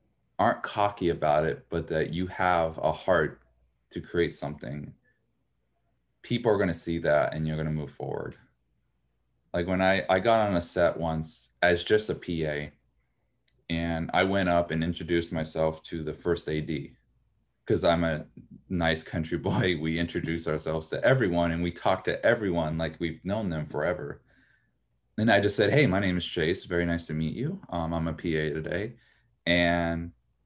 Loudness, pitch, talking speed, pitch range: -28 LUFS, 85 Hz, 175 wpm, 80-85 Hz